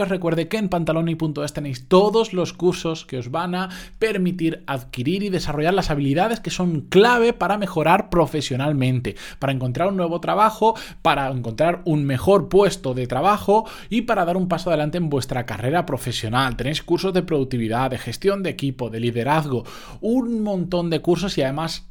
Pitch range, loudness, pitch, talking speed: 135-185 Hz, -21 LUFS, 165 Hz, 175 wpm